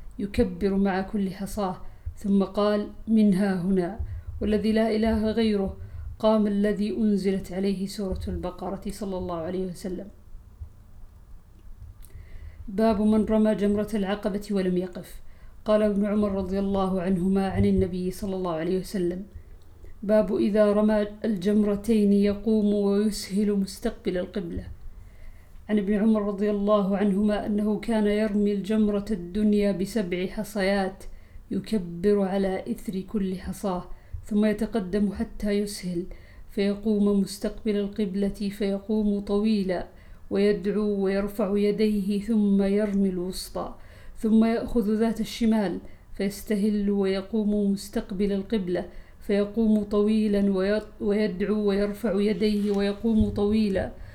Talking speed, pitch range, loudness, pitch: 105 wpm, 190-210 Hz, -26 LUFS, 205 Hz